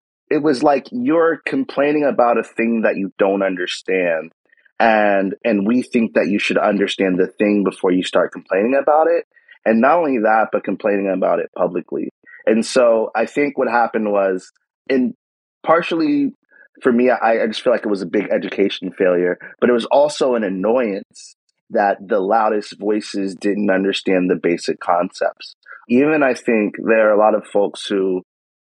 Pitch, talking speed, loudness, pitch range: 110 Hz, 175 wpm, -17 LUFS, 95-130 Hz